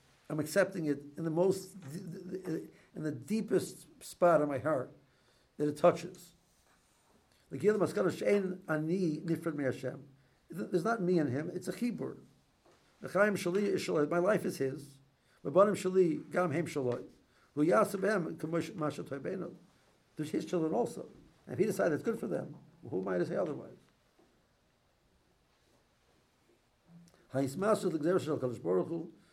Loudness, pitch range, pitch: -33 LUFS, 145-185 Hz, 165 Hz